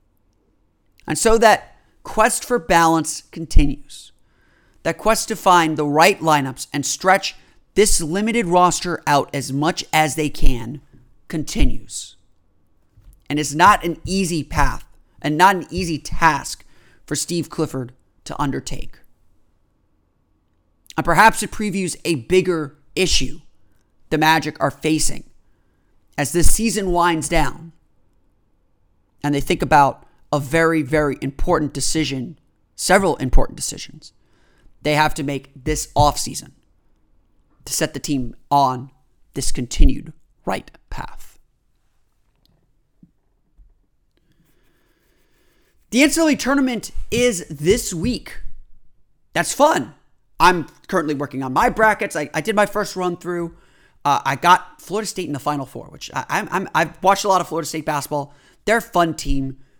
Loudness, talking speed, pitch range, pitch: -19 LUFS, 130 wpm, 130-175 Hz, 150 Hz